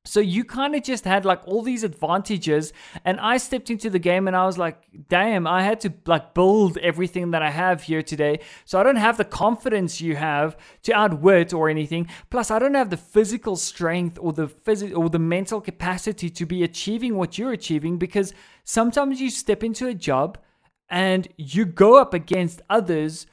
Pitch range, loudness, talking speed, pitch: 170-215 Hz, -22 LUFS, 200 wpm, 185 Hz